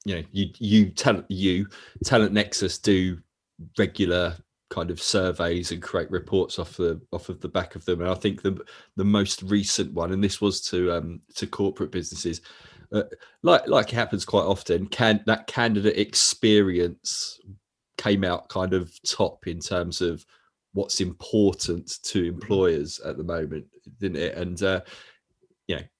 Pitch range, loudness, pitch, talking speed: 90-100 Hz, -25 LUFS, 95 Hz, 165 wpm